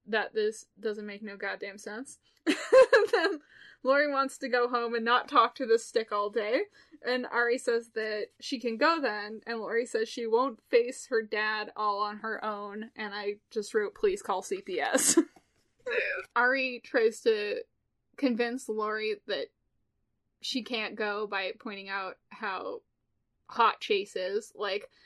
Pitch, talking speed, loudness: 245 Hz, 160 wpm, -30 LUFS